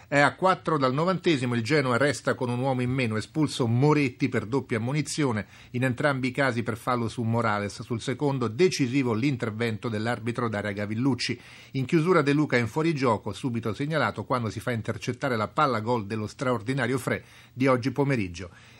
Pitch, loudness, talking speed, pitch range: 125 Hz, -26 LUFS, 170 wpm, 115-140 Hz